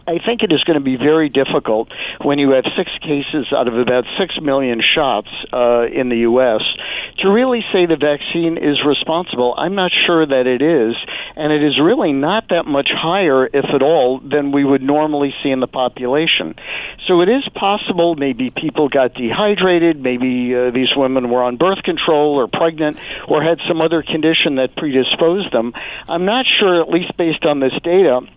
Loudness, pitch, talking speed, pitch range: -15 LUFS, 150 Hz, 190 wpm, 130-170 Hz